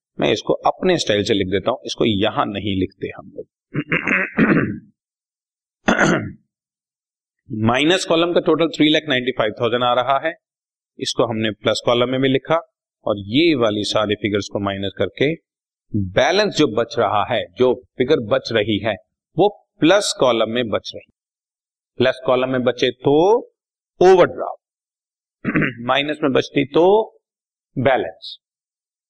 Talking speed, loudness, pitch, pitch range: 140 wpm, -18 LUFS, 130 Hz, 115-165 Hz